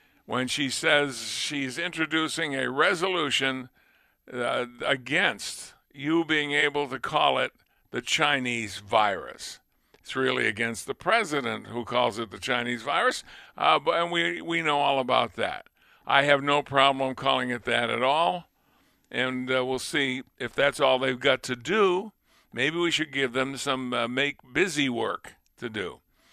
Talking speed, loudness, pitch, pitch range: 155 wpm, -26 LUFS, 135 Hz, 125-145 Hz